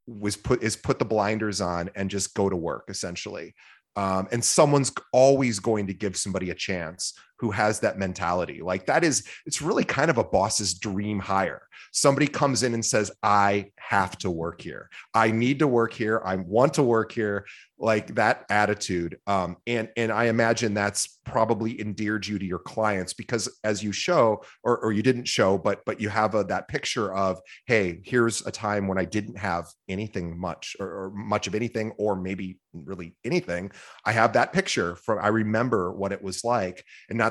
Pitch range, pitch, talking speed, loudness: 95-115 Hz, 105 Hz, 195 wpm, -25 LUFS